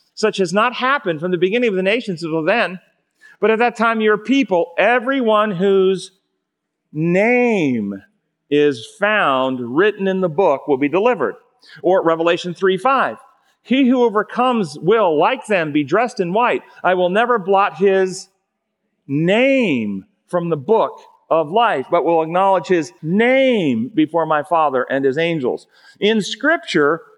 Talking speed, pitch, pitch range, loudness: 150 wpm, 195 Hz, 170-235 Hz, -17 LUFS